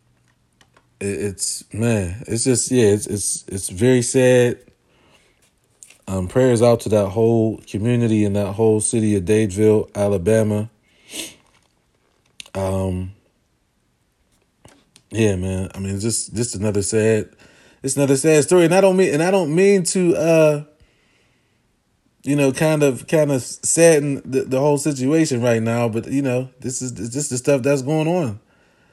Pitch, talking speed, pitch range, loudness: 120 Hz, 150 wpm, 105-140 Hz, -18 LUFS